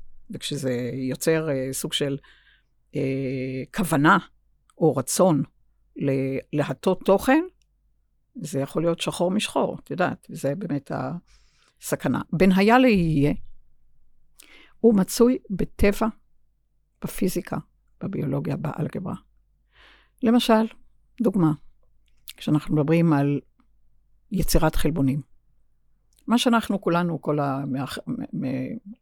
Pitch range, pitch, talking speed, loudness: 135-205 Hz, 155 Hz, 90 wpm, -24 LUFS